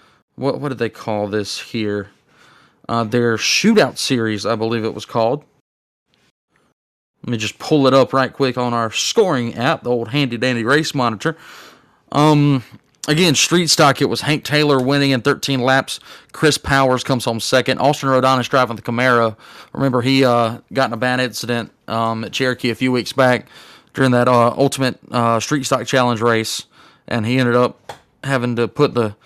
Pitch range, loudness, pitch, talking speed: 115-135 Hz, -17 LUFS, 125 Hz, 185 wpm